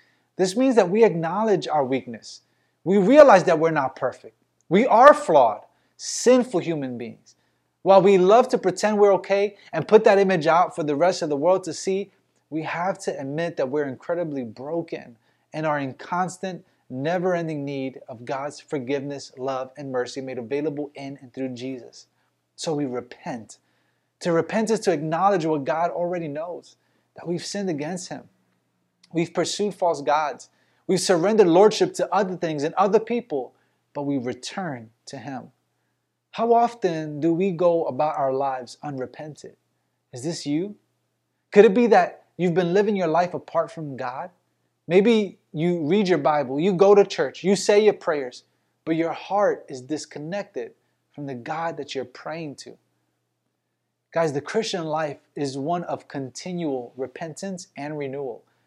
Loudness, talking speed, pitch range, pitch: -22 LUFS, 165 wpm, 140-190 Hz, 165 Hz